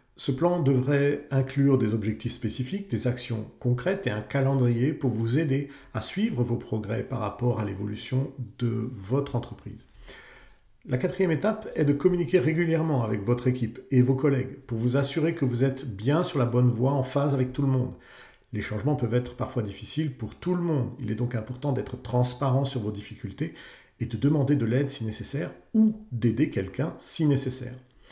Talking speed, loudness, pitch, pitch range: 190 wpm, -27 LUFS, 130 Hz, 120-145 Hz